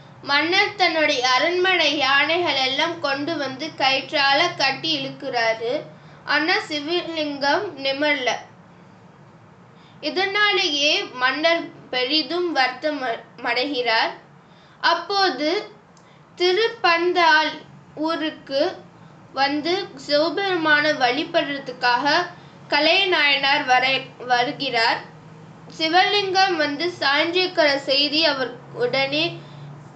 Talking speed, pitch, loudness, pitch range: 60 wpm, 300 Hz, -20 LUFS, 265-335 Hz